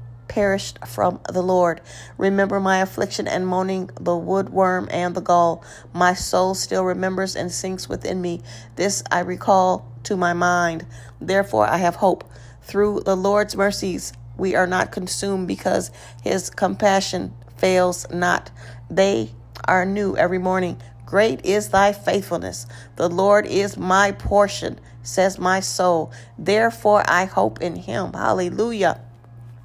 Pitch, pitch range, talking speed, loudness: 185 Hz, 135-195 Hz, 140 wpm, -21 LUFS